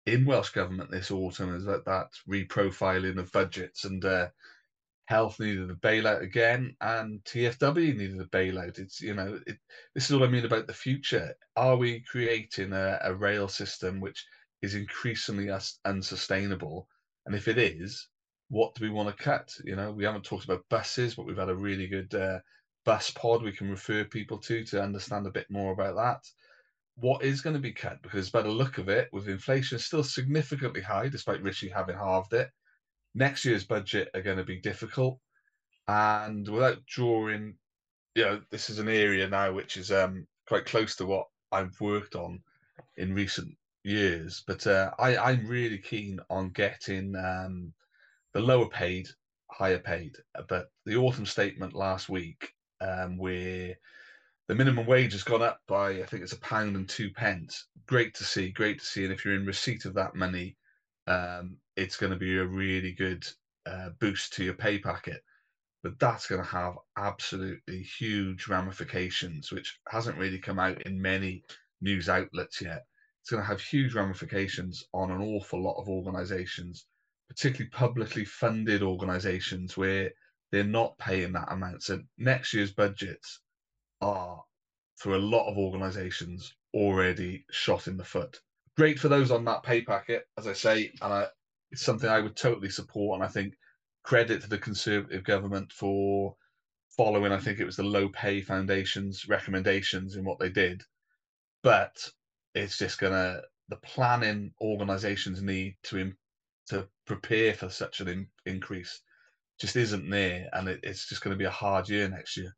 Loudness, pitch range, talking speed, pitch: -30 LUFS, 95-110 Hz, 175 wpm, 100 Hz